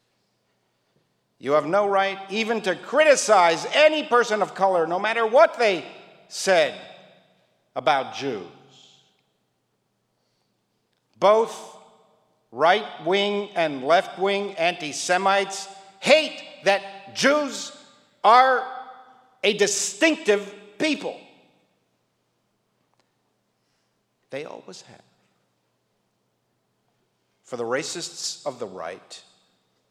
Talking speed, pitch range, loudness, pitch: 85 wpm, 170-245 Hz, -21 LUFS, 200 Hz